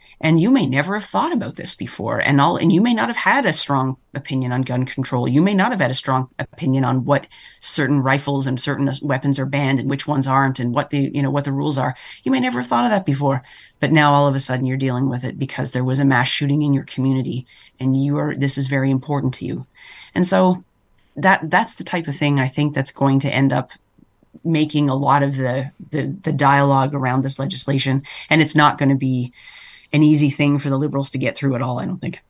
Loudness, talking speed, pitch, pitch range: -18 LUFS, 250 wpm, 140 Hz, 130-145 Hz